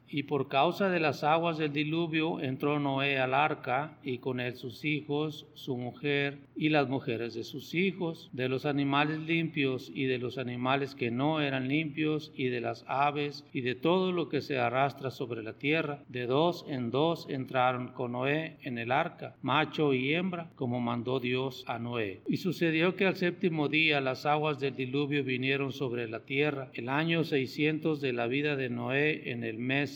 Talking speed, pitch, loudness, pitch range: 190 wpm, 140 Hz, -31 LUFS, 130-155 Hz